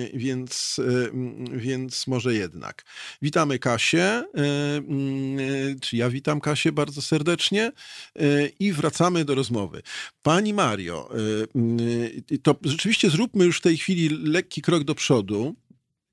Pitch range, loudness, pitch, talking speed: 125-165 Hz, -24 LUFS, 145 Hz, 110 wpm